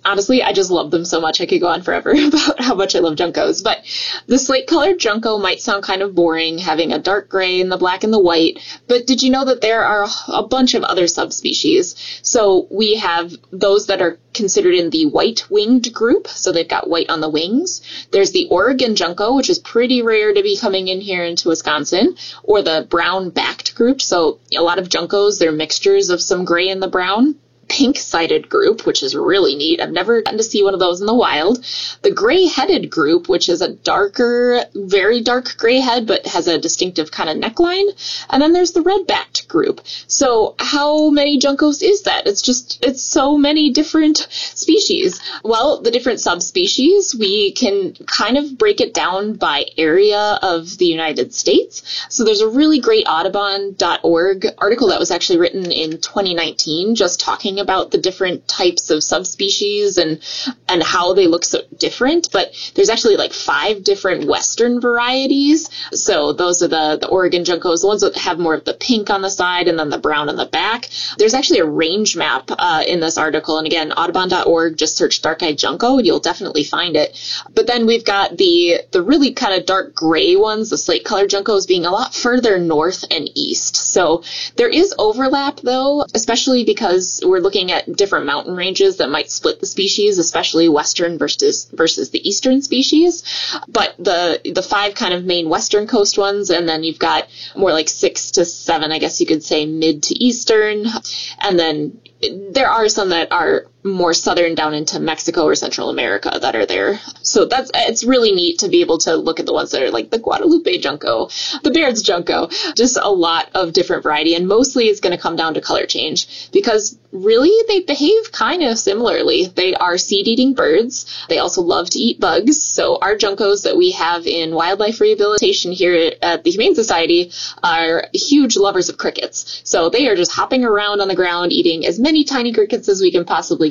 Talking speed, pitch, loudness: 200 wpm, 240 Hz, -15 LUFS